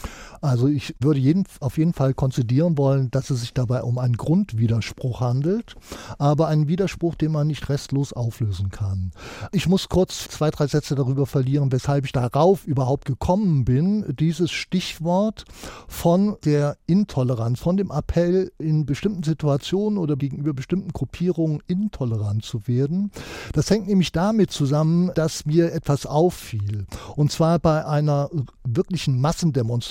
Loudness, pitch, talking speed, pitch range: -22 LUFS, 150 Hz, 145 wpm, 130-170 Hz